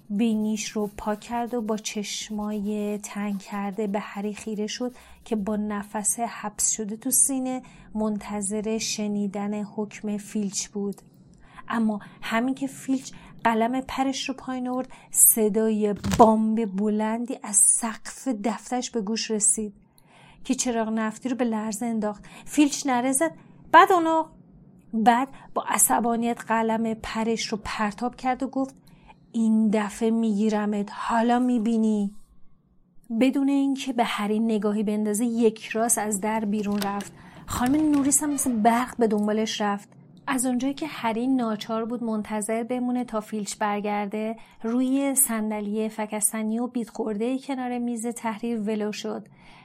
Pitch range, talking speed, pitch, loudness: 210-240 Hz, 135 wpm, 220 Hz, -25 LUFS